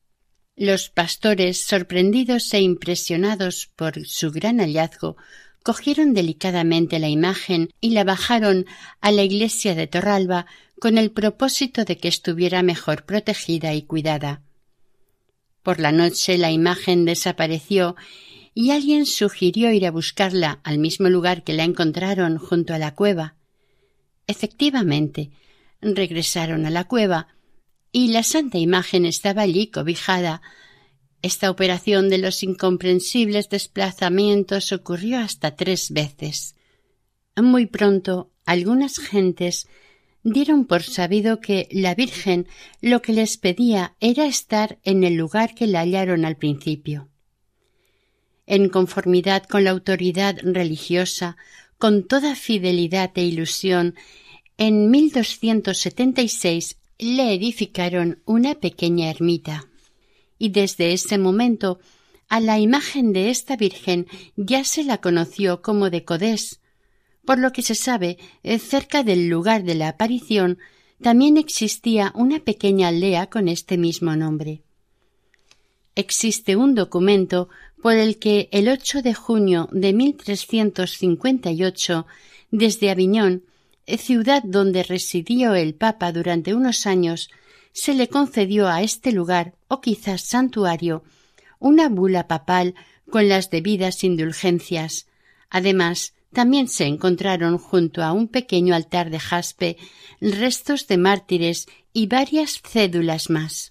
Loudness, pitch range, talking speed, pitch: -20 LUFS, 175-220 Hz, 120 wpm, 190 Hz